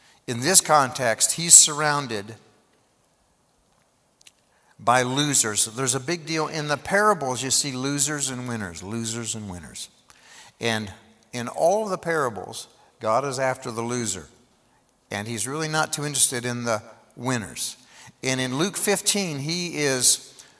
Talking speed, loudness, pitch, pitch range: 140 wpm, -21 LUFS, 130 Hz, 115-150 Hz